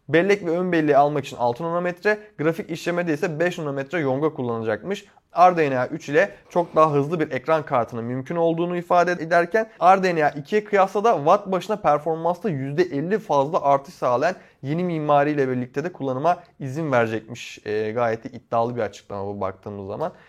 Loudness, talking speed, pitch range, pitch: -22 LUFS, 160 wpm, 135-175 Hz, 155 Hz